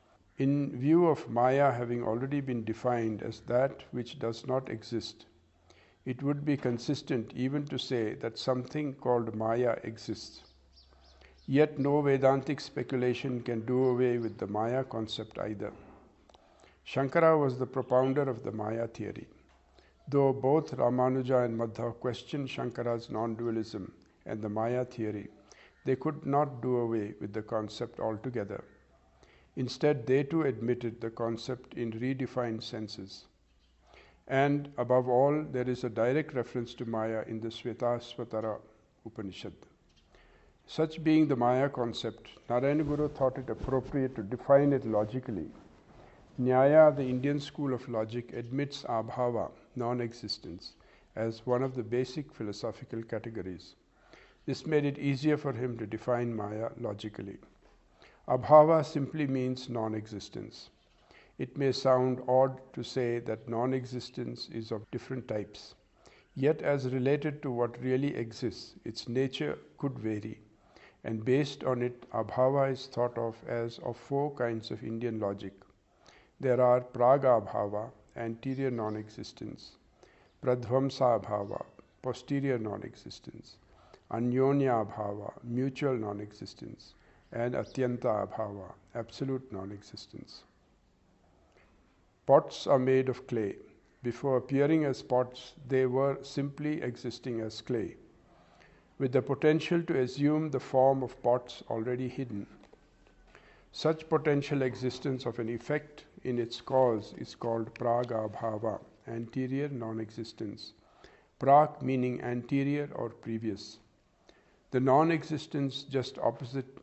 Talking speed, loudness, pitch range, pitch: 130 wpm, -31 LUFS, 115-135 Hz, 125 Hz